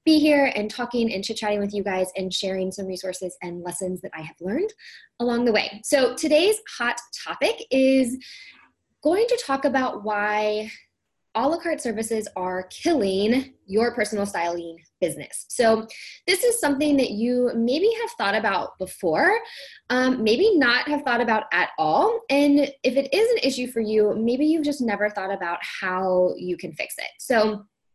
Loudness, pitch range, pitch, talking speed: -23 LUFS, 195-285 Hz, 235 Hz, 175 wpm